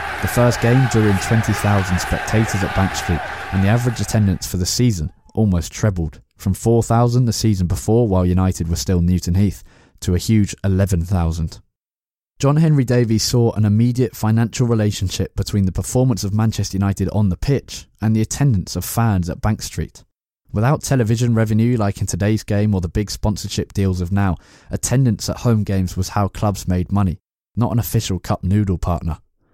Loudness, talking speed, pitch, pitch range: -18 LUFS, 180 wpm, 100 Hz, 95-115 Hz